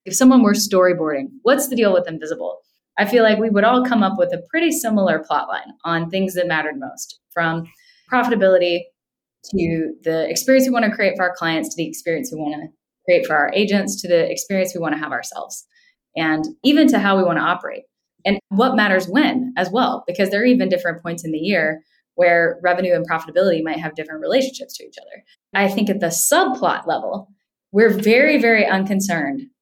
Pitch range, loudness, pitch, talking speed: 170-250 Hz, -18 LUFS, 195 Hz, 200 wpm